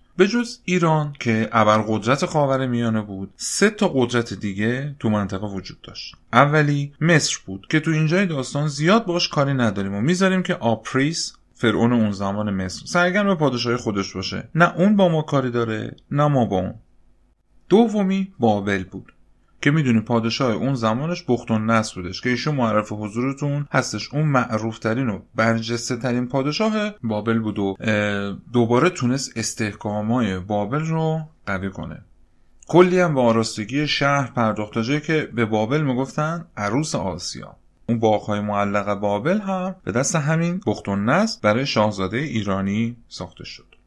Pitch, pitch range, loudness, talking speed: 120 Hz, 105-150 Hz, -21 LUFS, 155 wpm